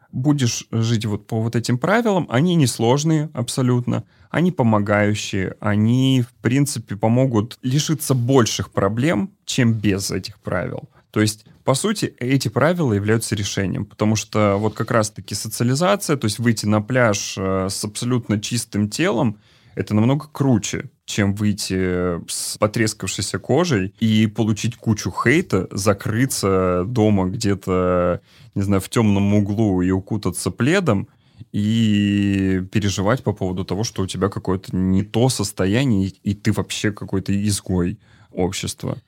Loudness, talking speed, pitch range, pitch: -20 LUFS, 135 wpm, 100-125 Hz, 110 Hz